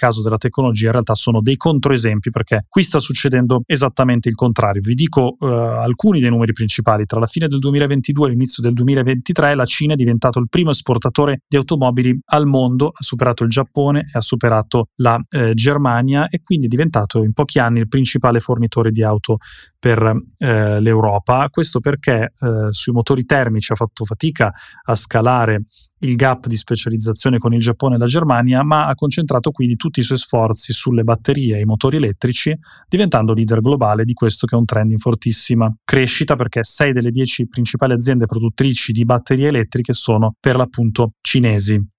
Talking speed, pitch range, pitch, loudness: 185 wpm, 115-135 Hz, 125 Hz, -16 LUFS